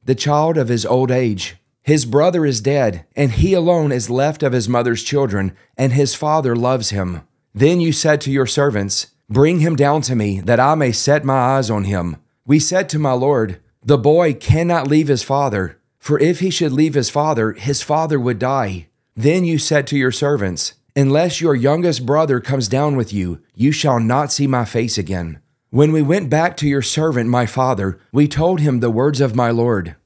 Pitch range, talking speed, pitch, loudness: 120-150 Hz, 205 wpm, 135 Hz, -16 LUFS